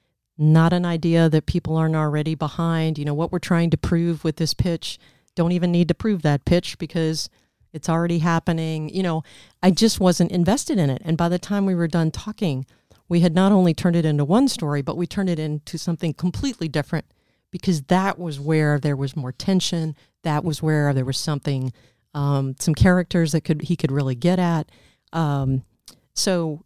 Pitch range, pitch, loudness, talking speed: 150-175 Hz, 165 Hz, -21 LUFS, 200 wpm